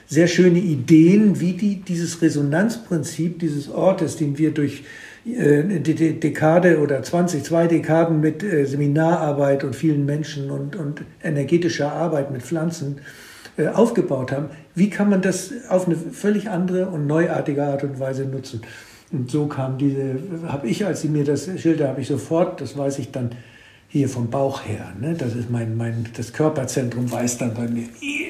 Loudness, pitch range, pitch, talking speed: -21 LUFS, 140-170 Hz, 150 Hz, 175 wpm